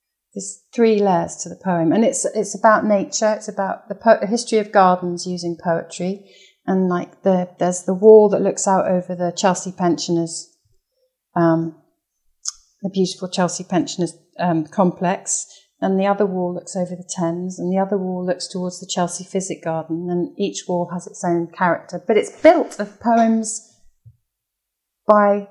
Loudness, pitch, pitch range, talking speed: -19 LUFS, 185 Hz, 175-205 Hz, 170 wpm